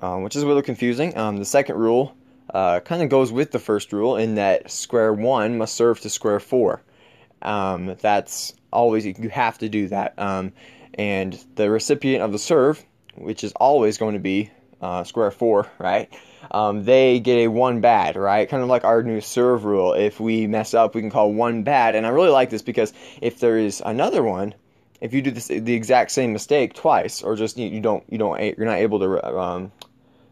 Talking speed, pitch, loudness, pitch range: 210 wpm, 110 Hz, -20 LUFS, 105-125 Hz